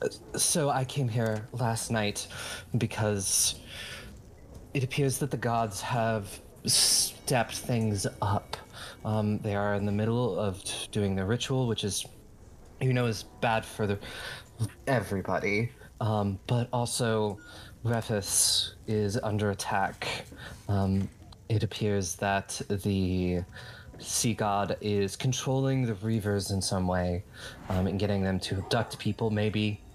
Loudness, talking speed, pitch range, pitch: -29 LUFS, 130 wpm, 100-115 Hz, 105 Hz